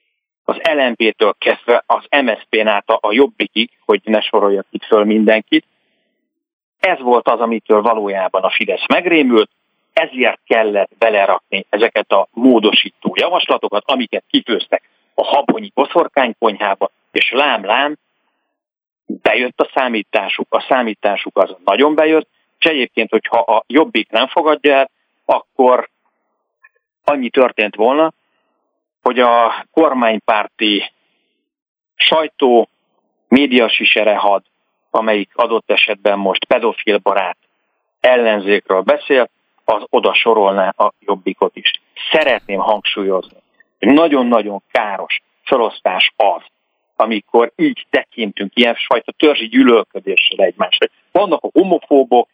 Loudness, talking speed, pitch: -14 LUFS, 105 wpm, 135 Hz